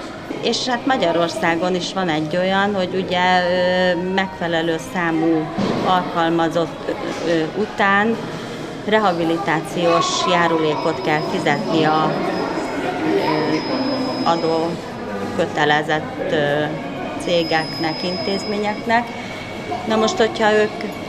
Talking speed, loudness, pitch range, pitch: 75 wpm, -19 LUFS, 165-210 Hz, 180 Hz